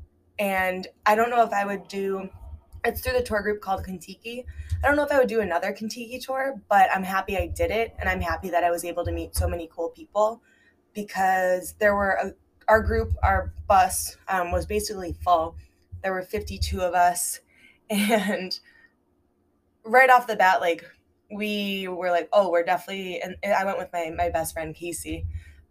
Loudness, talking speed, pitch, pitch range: -25 LUFS, 190 wpm, 185 Hz, 160-210 Hz